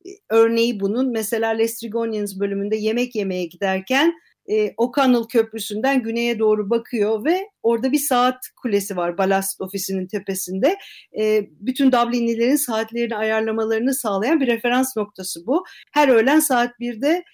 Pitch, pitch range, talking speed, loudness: 230 Hz, 210-255 Hz, 130 wpm, -20 LUFS